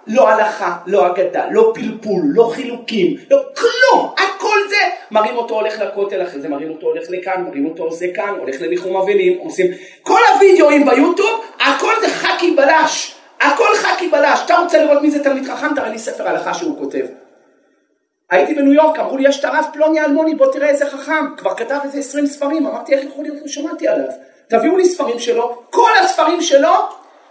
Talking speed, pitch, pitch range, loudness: 180 wpm, 290 Hz, 235-345 Hz, -15 LUFS